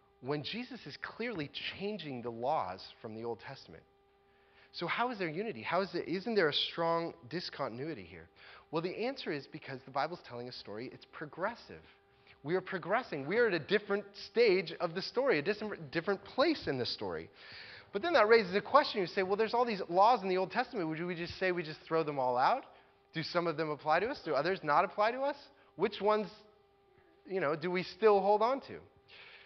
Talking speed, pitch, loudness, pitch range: 215 wpm, 185 Hz, -34 LUFS, 145-215 Hz